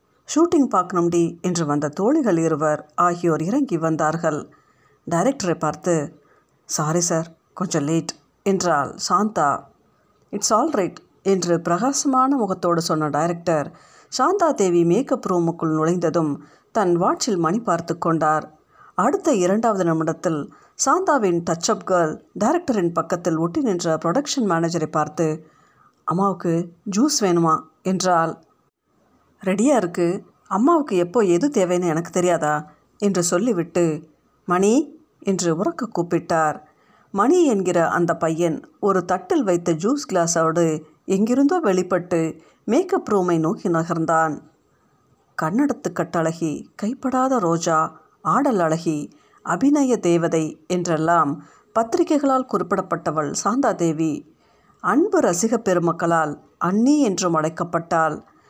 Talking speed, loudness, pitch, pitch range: 100 wpm, -21 LUFS, 175 Hz, 165-210 Hz